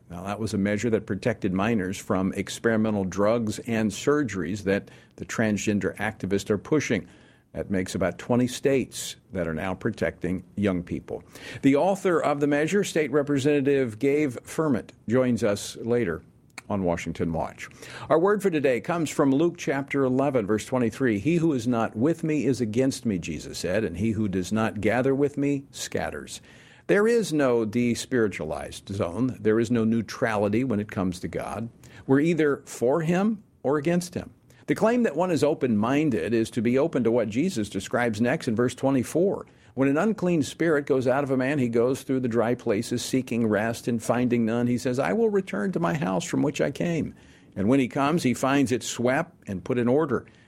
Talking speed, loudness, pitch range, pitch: 190 wpm, -25 LUFS, 105-145 Hz, 120 Hz